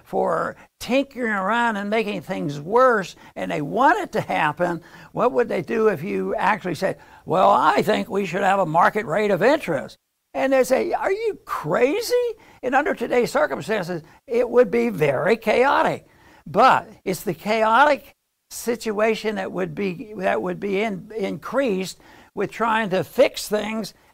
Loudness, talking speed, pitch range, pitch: -21 LUFS, 160 wpm, 190-235 Hz, 215 Hz